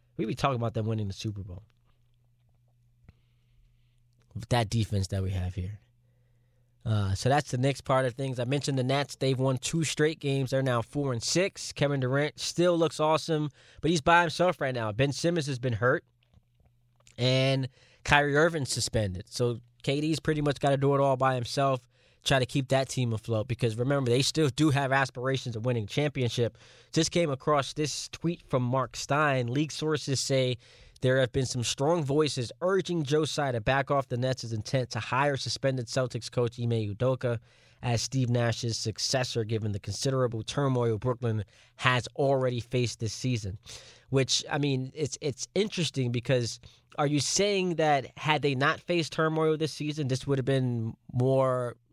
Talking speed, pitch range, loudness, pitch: 180 wpm, 120-145 Hz, -28 LUFS, 130 Hz